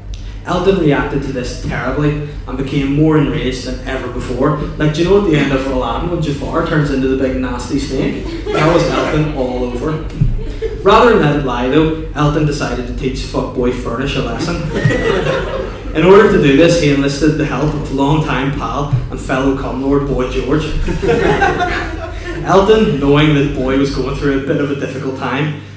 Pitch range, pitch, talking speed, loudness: 130-155 Hz, 140 Hz, 180 wpm, -15 LUFS